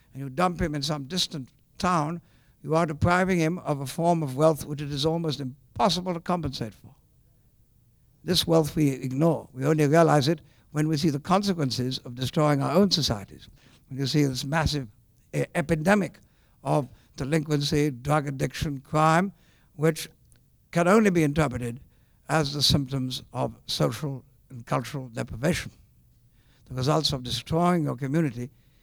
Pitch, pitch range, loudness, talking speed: 145 Hz, 130-160 Hz, -26 LUFS, 155 wpm